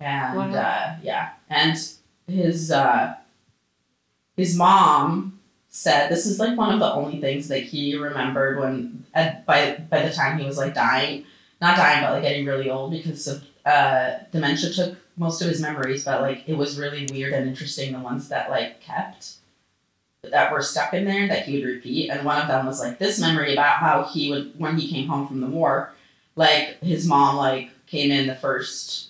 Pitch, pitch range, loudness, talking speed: 145 Hz, 135-160 Hz, -22 LUFS, 195 wpm